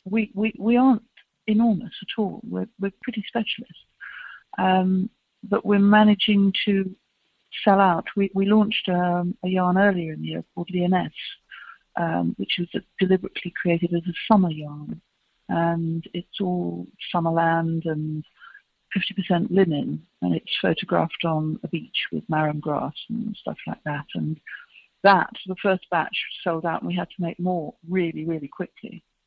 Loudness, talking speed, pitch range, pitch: -24 LUFS, 160 wpm, 165-205 Hz, 180 Hz